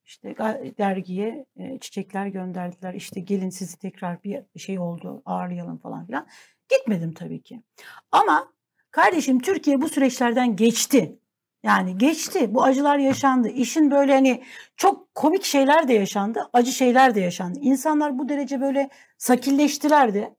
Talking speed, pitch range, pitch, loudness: 135 wpm, 195-275 Hz, 250 Hz, -21 LUFS